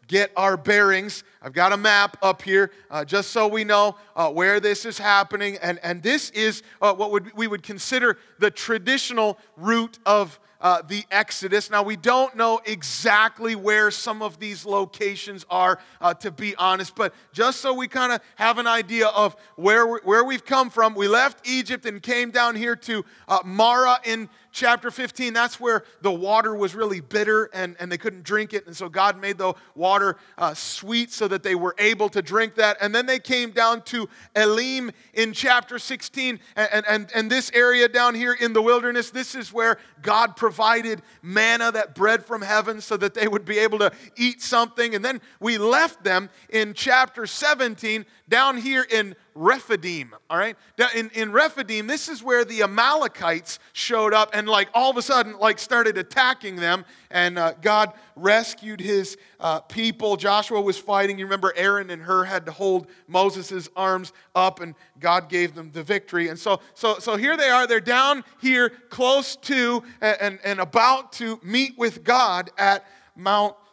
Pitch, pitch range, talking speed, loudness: 215 Hz, 195-235 Hz, 190 wpm, -21 LUFS